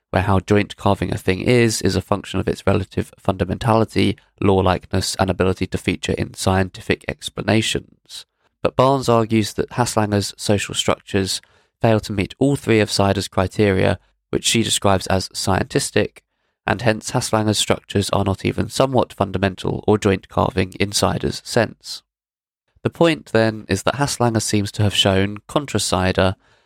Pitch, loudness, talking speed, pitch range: 100 Hz, -19 LUFS, 155 wpm, 95-110 Hz